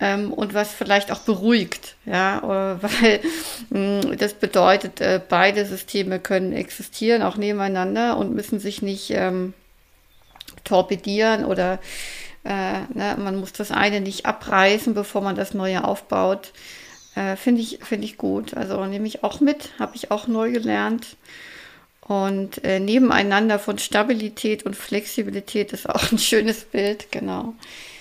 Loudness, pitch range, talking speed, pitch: -22 LUFS, 195-225 Hz, 135 wpm, 205 Hz